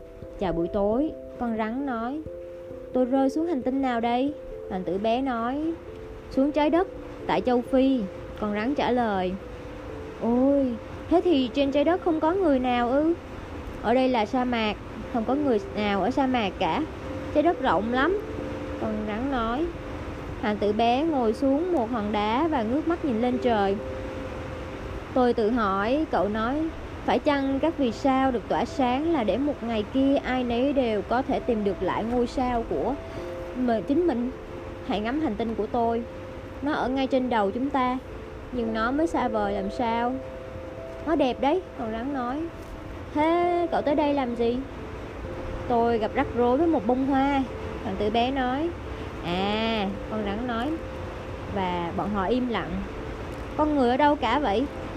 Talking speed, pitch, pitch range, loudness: 180 wpm, 250 Hz, 225-280 Hz, -26 LUFS